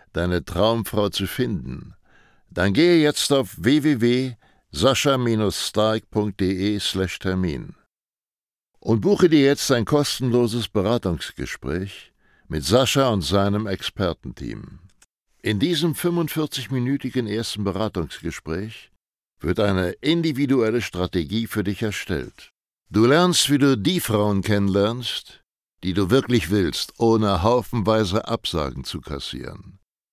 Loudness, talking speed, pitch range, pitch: -22 LUFS, 100 wpm, 95-130 Hz, 110 Hz